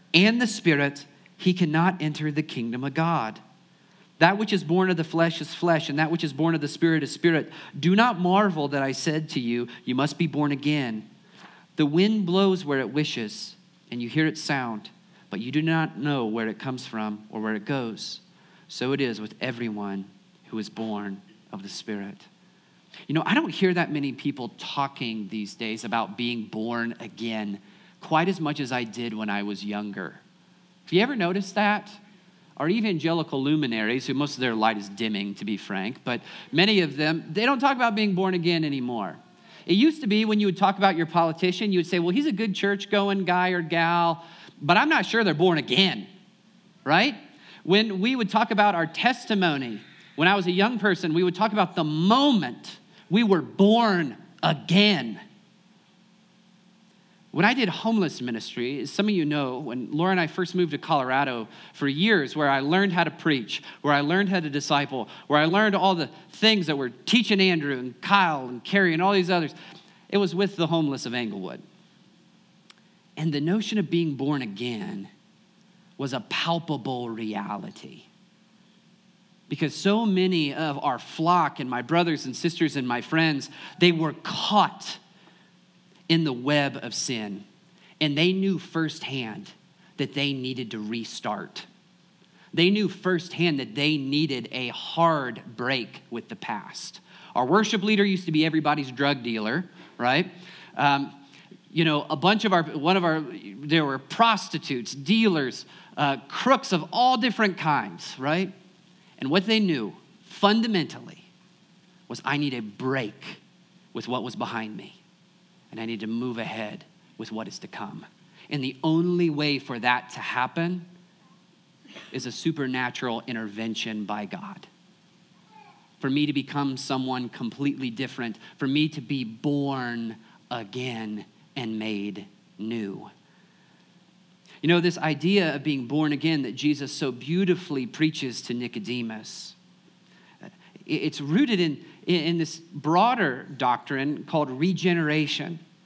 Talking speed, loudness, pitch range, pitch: 170 wpm, -25 LUFS, 135-190 Hz, 165 Hz